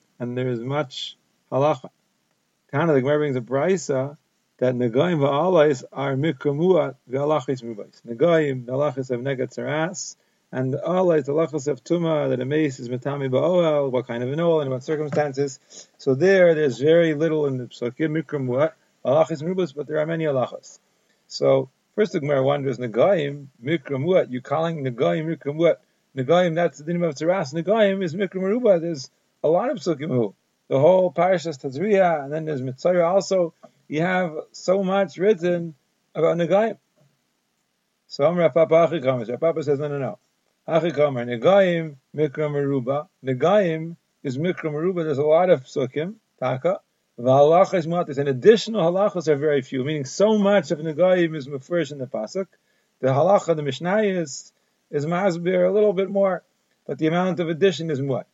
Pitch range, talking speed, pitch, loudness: 140-175 Hz, 165 wpm, 155 Hz, -22 LUFS